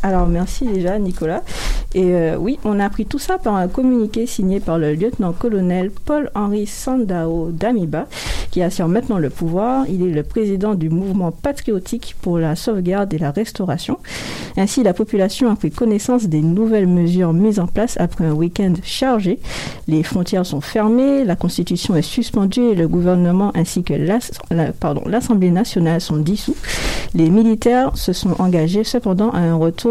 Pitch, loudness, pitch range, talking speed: 195 Hz, -18 LUFS, 170-225 Hz, 175 wpm